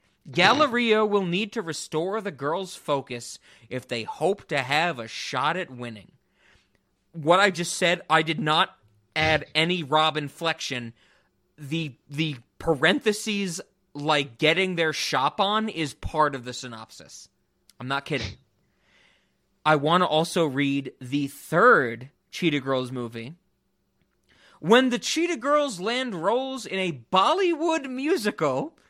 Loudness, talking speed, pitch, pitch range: -24 LUFS, 135 wpm, 160 Hz, 140-200 Hz